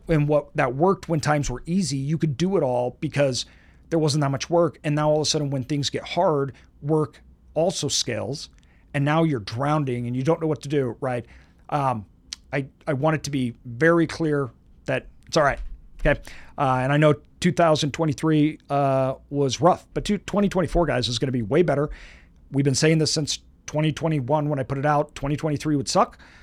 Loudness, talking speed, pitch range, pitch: -23 LUFS, 200 wpm, 130-155 Hz, 145 Hz